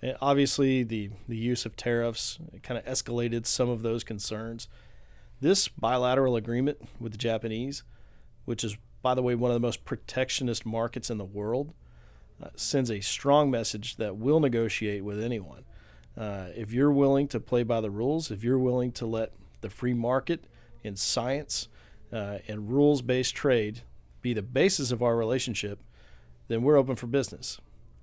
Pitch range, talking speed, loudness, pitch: 105-125 Hz, 170 wpm, -28 LUFS, 115 Hz